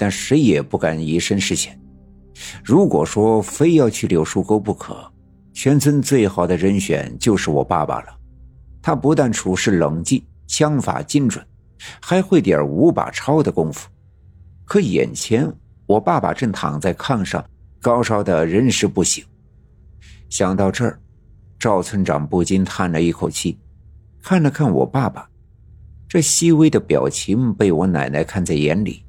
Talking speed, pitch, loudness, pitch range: 215 characters per minute, 100 Hz, -18 LUFS, 85-115 Hz